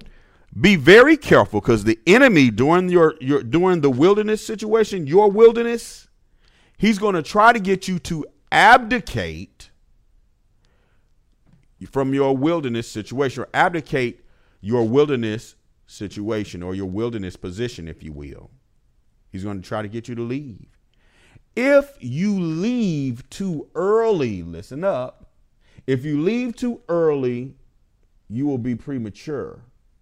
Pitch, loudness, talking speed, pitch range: 130 Hz, -19 LUFS, 130 wpm, 110-180 Hz